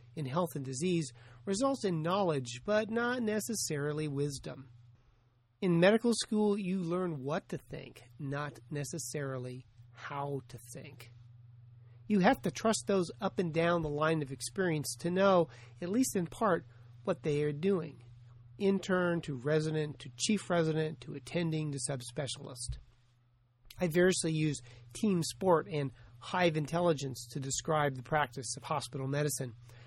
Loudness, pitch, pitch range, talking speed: -33 LUFS, 150 Hz, 125-175 Hz, 145 wpm